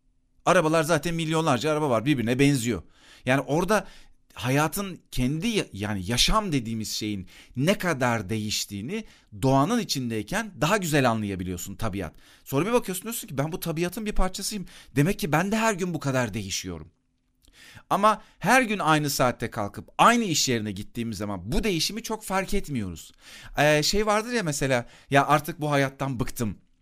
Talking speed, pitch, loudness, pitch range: 150 wpm, 145 Hz, -25 LUFS, 115-190 Hz